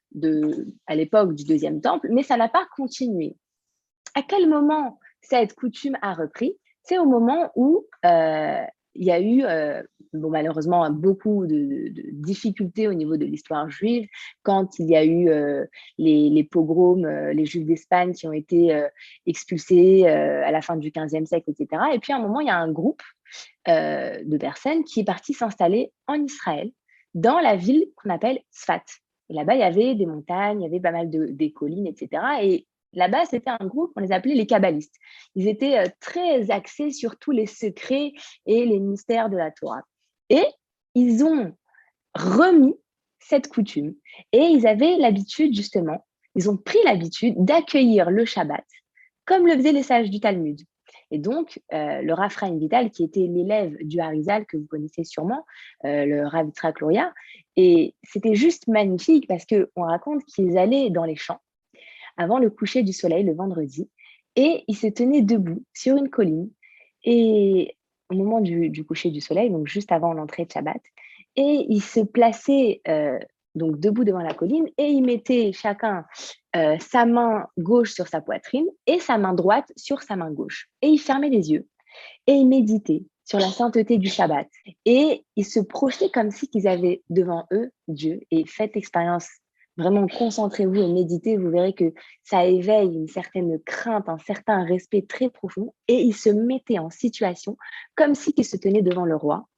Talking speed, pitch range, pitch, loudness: 180 wpm, 170-260 Hz, 210 Hz, -22 LUFS